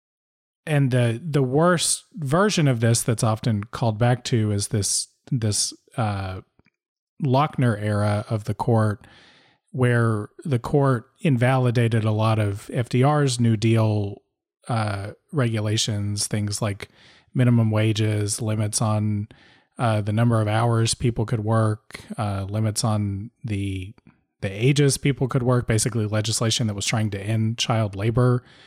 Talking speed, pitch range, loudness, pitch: 135 wpm, 105-125 Hz, -22 LUFS, 115 Hz